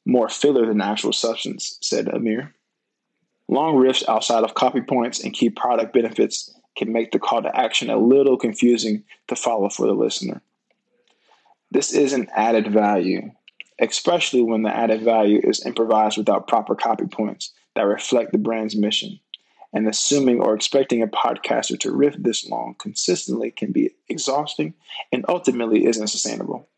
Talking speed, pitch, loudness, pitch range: 155 wpm, 115 Hz, -20 LUFS, 110-130 Hz